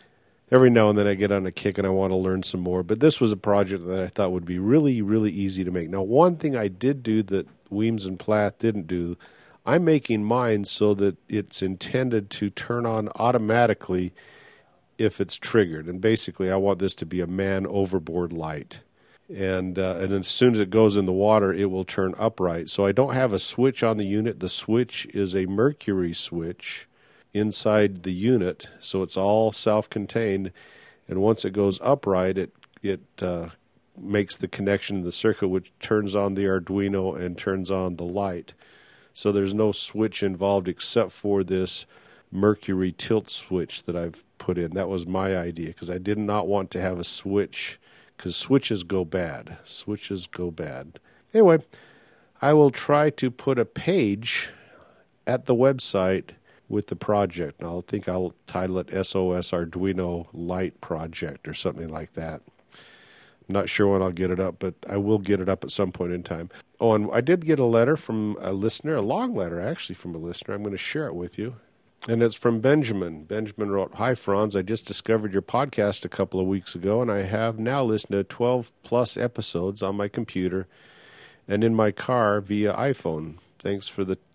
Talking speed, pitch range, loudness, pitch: 195 wpm, 95-110 Hz, -24 LUFS, 100 Hz